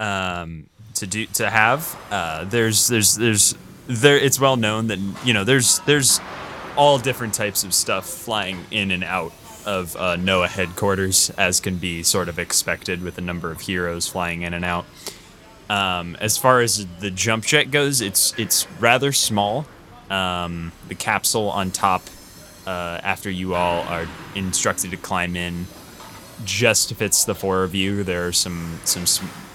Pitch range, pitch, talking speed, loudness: 90-110 Hz, 95 Hz, 170 wpm, -20 LUFS